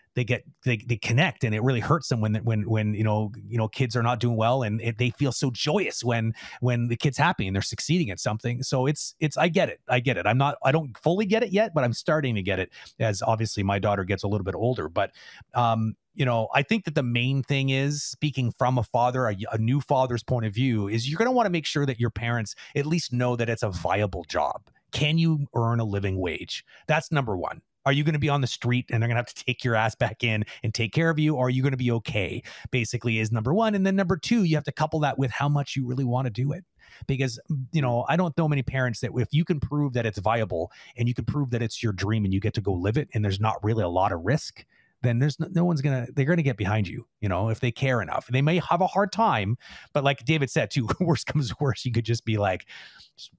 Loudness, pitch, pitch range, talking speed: -26 LUFS, 125 Hz, 115-145 Hz, 280 wpm